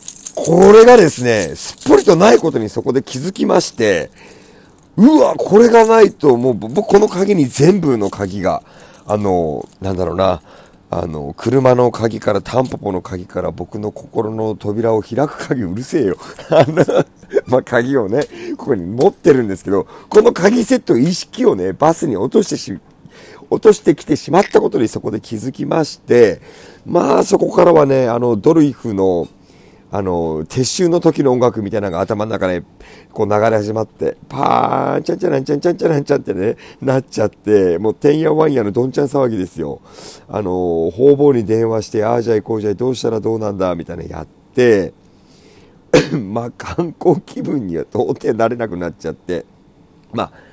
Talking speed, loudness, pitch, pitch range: 345 characters per minute, -14 LUFS, 120 Hz, 100-150 Hz